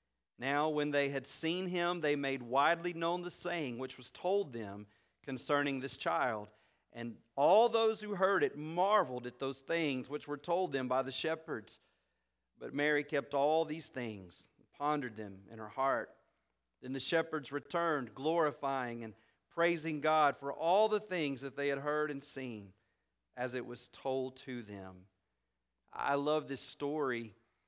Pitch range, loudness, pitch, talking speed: 120-155 Hz, -35 LUFS, 140 Hz, 165 wpm